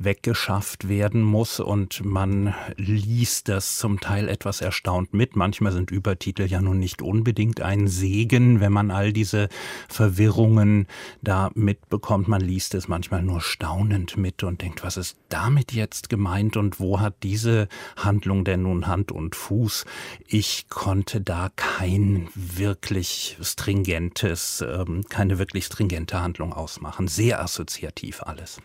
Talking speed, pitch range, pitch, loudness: 140 wpm, 95-105 Hz, 100 Hz, -24 LUFS